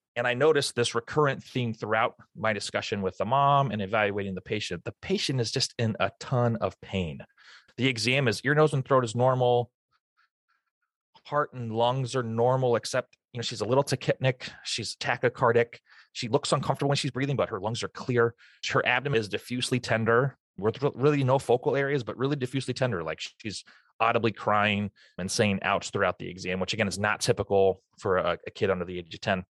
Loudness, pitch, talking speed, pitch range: -27 LUFS, 120 Hz, 195 wpm, 105-135 Hz